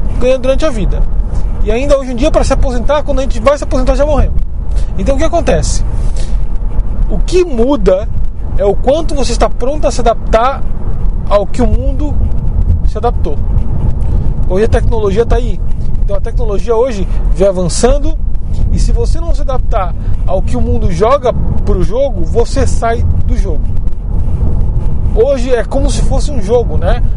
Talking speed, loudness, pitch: 170 wpm, -14 LUFS, 115 Hz